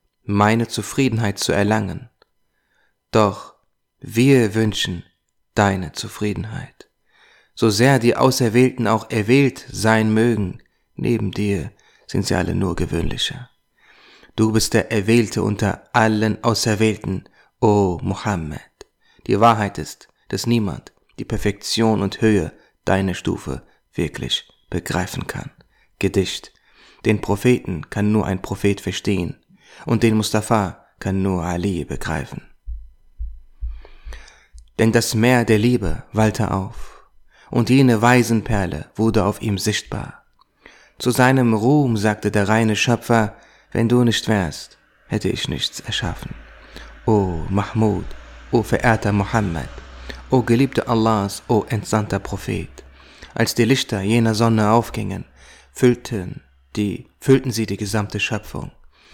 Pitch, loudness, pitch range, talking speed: 110 Hz, -19 LUFS, 100-115 Hz, 120 wpm